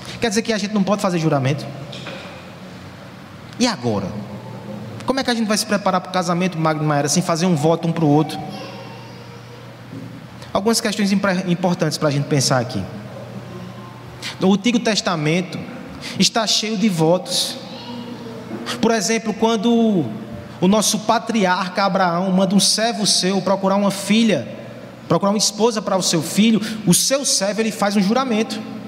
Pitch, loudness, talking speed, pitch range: 195 Hz, -18 LUFS, 155 wpm, 165-220 Hz